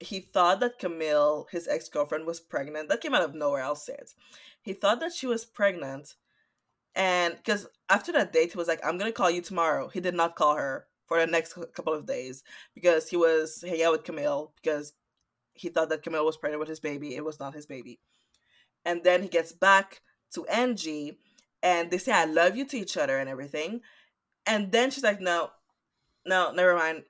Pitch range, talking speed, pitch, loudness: 155-195 Hz, 215 wpm, 170 Hz, -27 LUFS